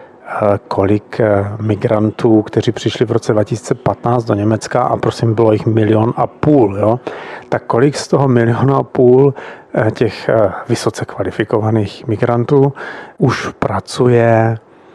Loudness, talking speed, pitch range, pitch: -14 LUFS, 120 wpm, 110-125 Hz, 115 Hz